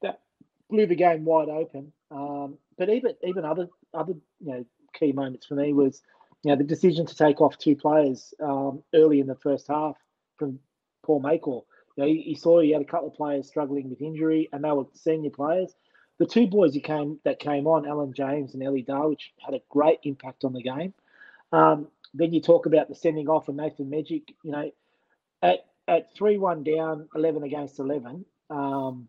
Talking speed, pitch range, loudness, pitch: 200 wpm, 140-160 Hz, -25 LUFS, 150 Hz